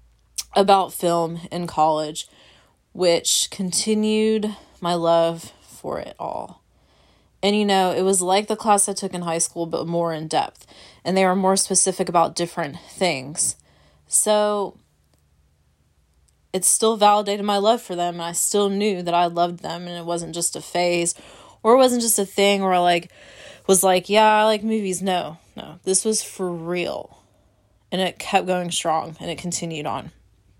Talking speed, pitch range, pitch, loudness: 175 wpm, 165-200 Hz, 175 Hz, -21 LUFS